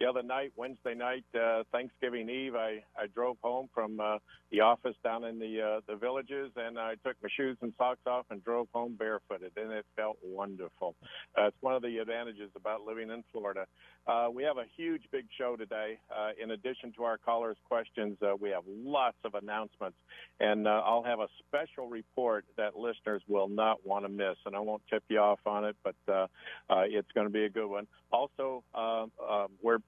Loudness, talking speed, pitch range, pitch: -35 LUFS, 210 wpm, 105-120 Hz, 110 Hz